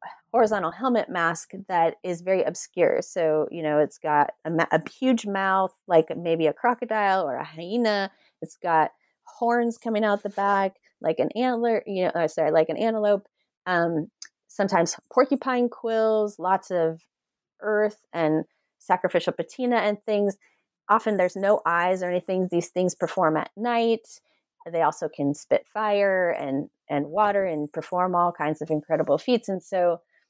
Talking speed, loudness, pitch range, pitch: 155 wpm, -25 LUFS, 170-220 Hz, 190 Hz